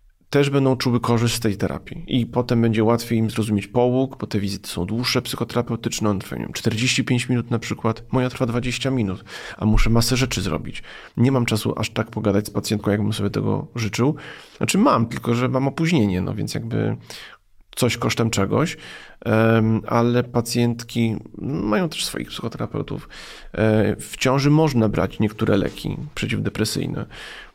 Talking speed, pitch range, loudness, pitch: 155 wpm, 105-125 Hz, -21 LUFS, 115 Hz